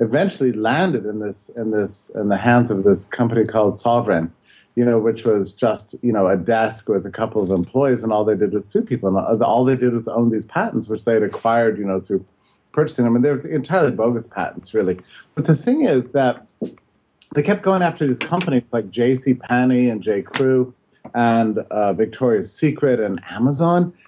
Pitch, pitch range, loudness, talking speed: 120 Hz, 110-135 Hz, -19 LUFS, 210 wpm